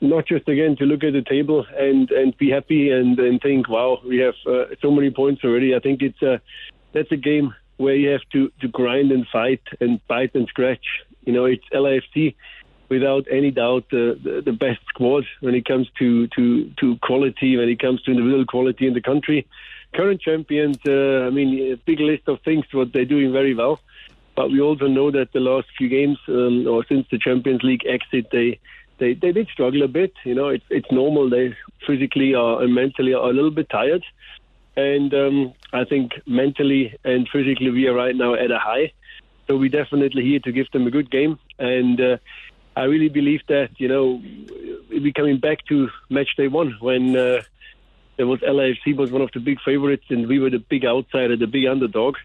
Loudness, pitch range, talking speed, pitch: -20 LUFS, 125-145 Hz, 210 wpm, 135 Hz